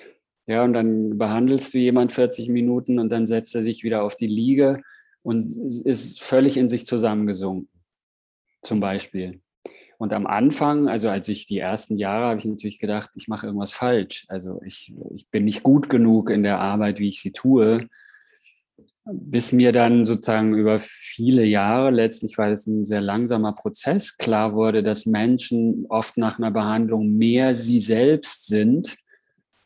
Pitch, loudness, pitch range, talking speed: 115 Hz, -21 LUFS, 105-125 Hz, 165 wpm